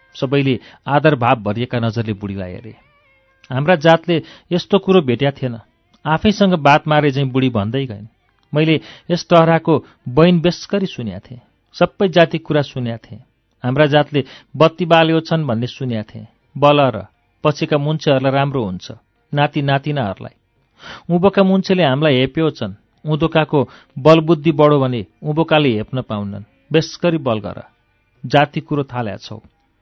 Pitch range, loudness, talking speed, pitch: 115-160 Hz, -16 LUFS, 135 wpm, 140 Hz